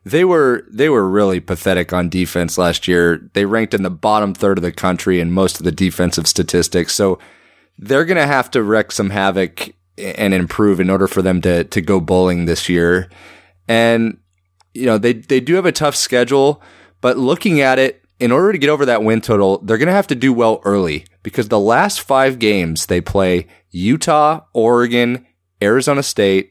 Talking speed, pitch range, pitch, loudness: 190 wpm, 90-120 Hz, 95 Hz, -15 LUFS